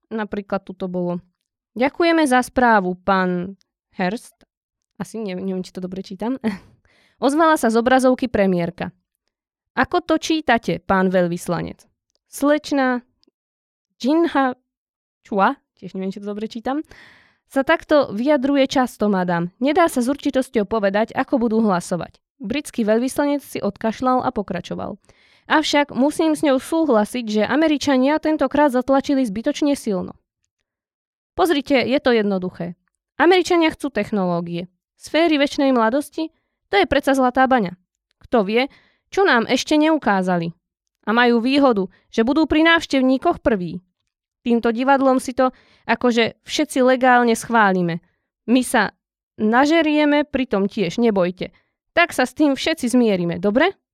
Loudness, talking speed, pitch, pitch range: -19 LUFS, 130 wpm, 250 Hz, 200-285 Hz